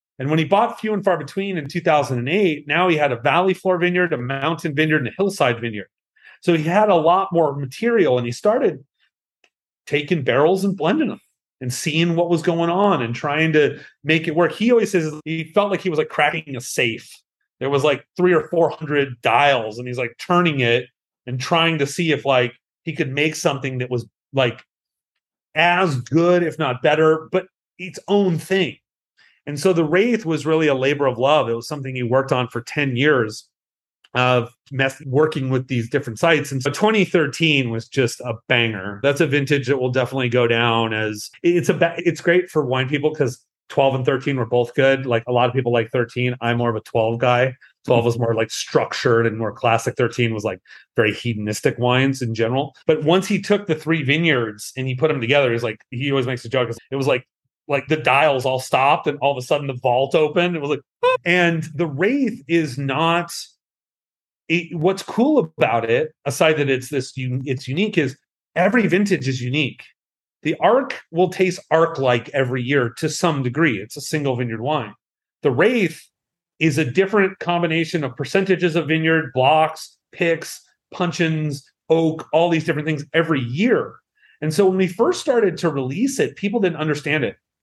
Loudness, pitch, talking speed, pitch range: -19 LUFS, 150 Hz, 205 wpm, 130-170 Hz